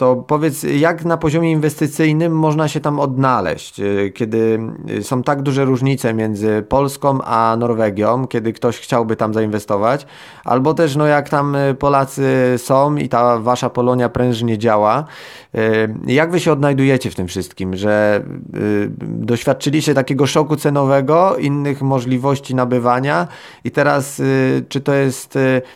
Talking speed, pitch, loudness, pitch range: 135 wpm, 130 Hz, -16 LUFS, 115-145 Hz